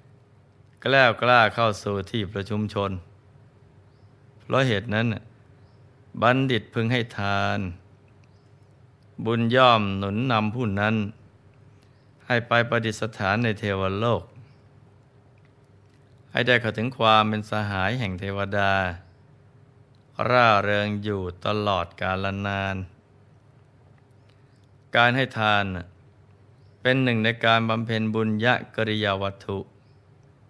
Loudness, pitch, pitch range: -23 LUFS, 110 Hz, 100-125 Hz